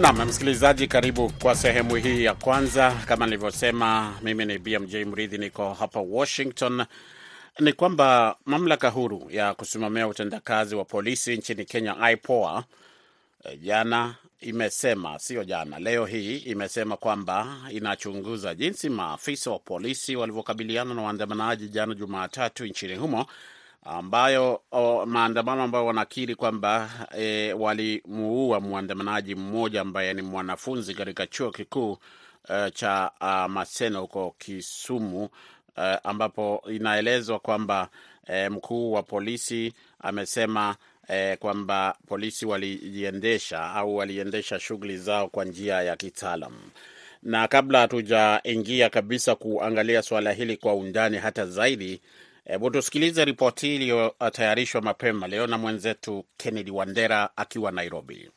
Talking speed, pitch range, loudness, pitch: 115 wpm, 100-120 Hz, -26 LUFS, 110 Hz